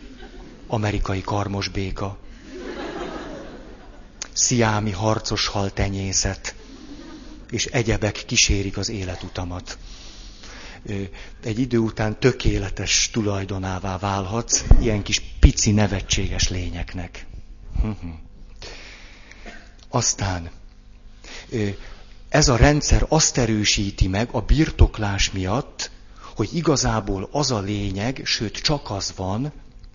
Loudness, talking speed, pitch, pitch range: -22 LUFS, 85 wpm, 105 Hz, 95-115 Hz